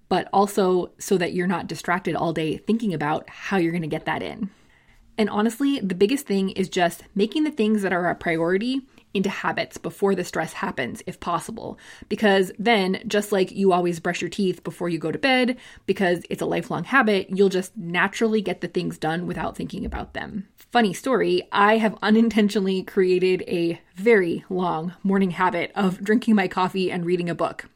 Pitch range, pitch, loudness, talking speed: 175-215 Hz, 190 Hz, -23 LUFS, 190 wpm